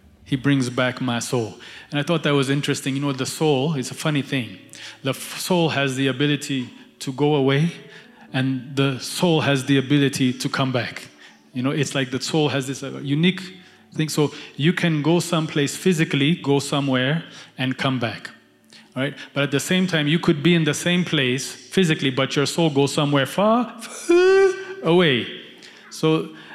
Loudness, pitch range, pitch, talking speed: -21 LUFS, 135-165 Hz, 140 Hz, 190 wpm